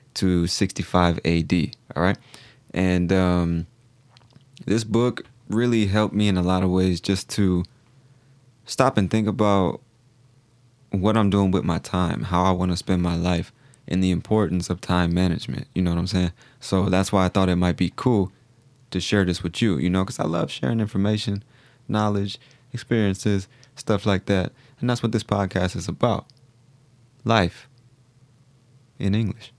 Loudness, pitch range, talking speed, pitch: -23 LUFS, 90-125 Hz, 170 wpm, 105 Hz